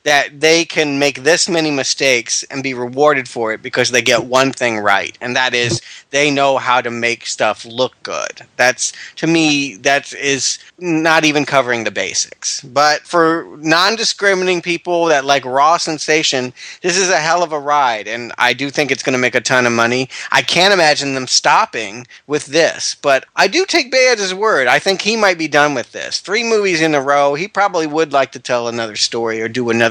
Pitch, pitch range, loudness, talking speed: 140 Hz, 125-165 Hz, -14 LUFS, 205 wpm